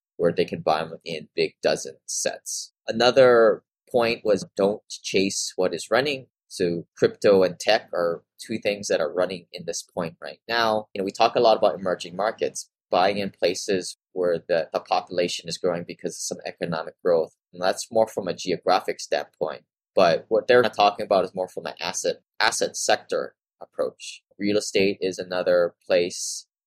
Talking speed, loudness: 180 wpm, -24 LUFS